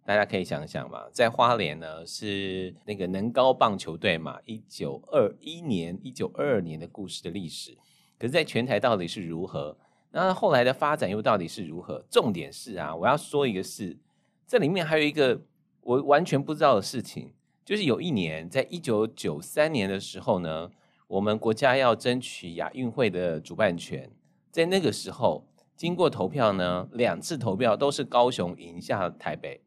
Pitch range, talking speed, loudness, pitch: 95-145 Hz, 275 characters per minute, -27 LUFS, 115 Hz